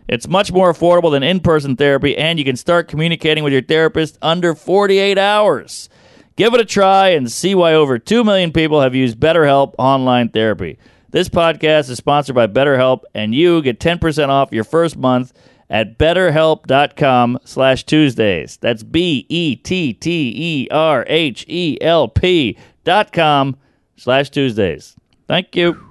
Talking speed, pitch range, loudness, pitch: 145 wpm, 135-170 Hz, -14 LUFS, 155 Hz